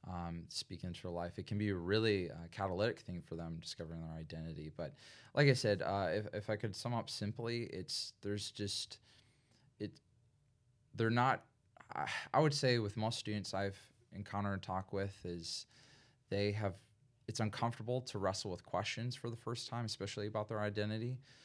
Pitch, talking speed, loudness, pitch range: 105 Hz, 180 wpm, -40 LUFS, 95-120 Hz